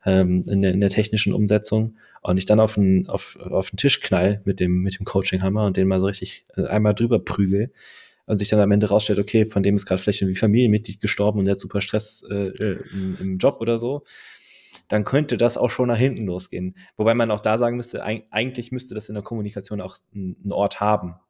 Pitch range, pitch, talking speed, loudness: 95-110 Hz, 105 Hz, 210 wpm, -22 LUFS